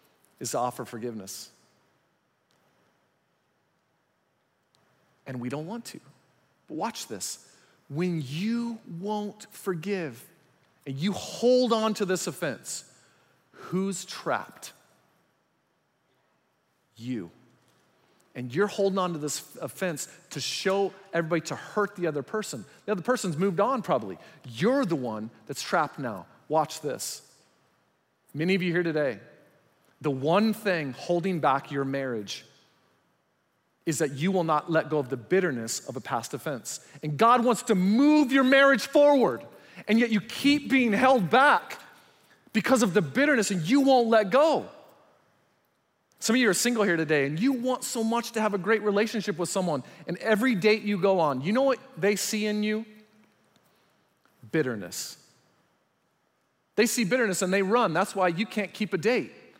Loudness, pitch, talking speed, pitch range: -26 LUFS, 195 Hz, 150 wpm, 155-225 Hz